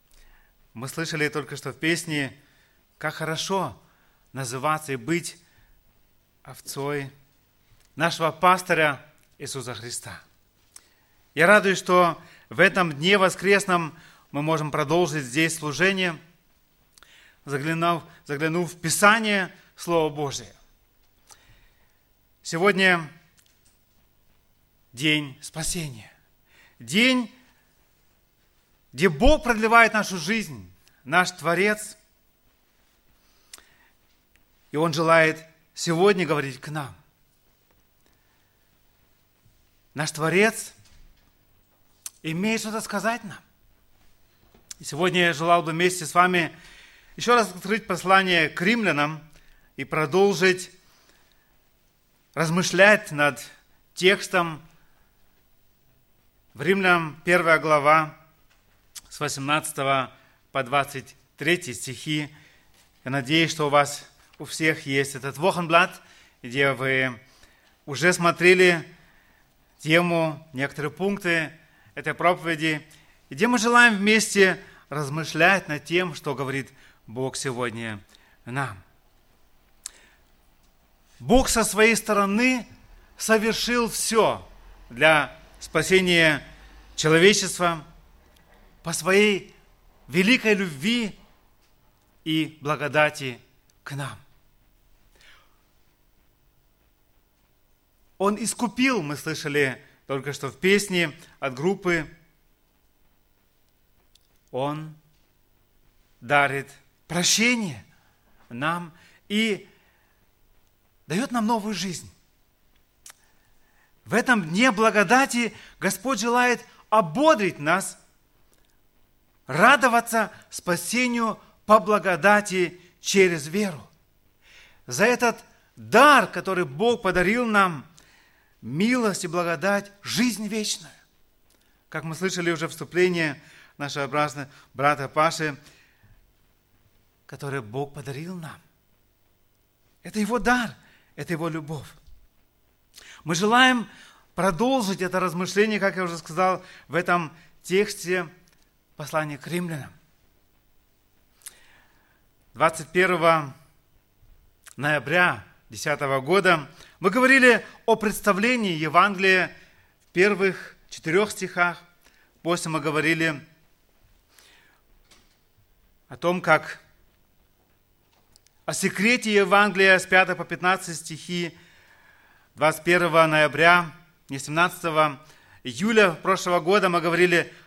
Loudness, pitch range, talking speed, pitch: -22 LUFS, 130-185 Hz, 85 wpm, 160 Hz